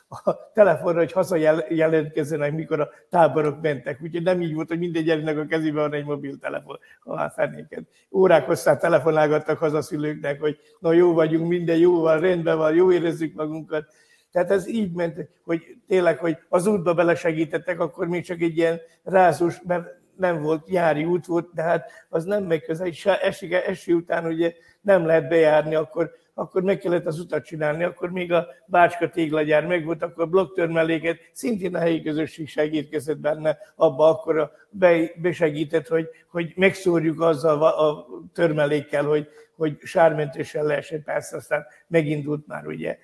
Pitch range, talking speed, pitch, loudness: 155-175 Hz, 165 wpm, 165 Hz, -22 LUFS